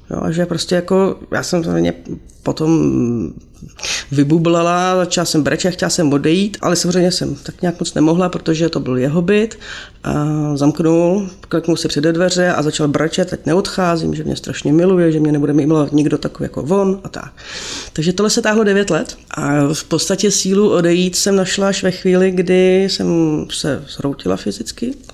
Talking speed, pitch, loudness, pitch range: 175 wpm, 170 Hz, -16 LUFS, 150-185 Hz